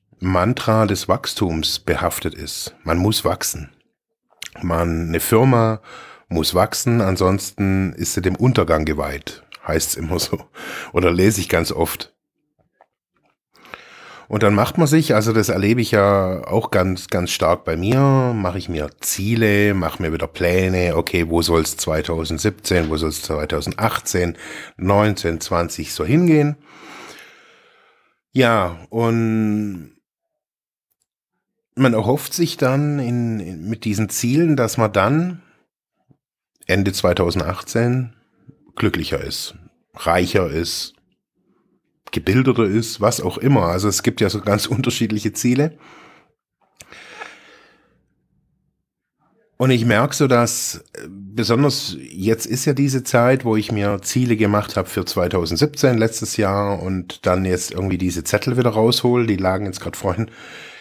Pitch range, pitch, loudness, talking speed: 90-120 Hz, 105 Hz, -19 LUFS, 130 wpm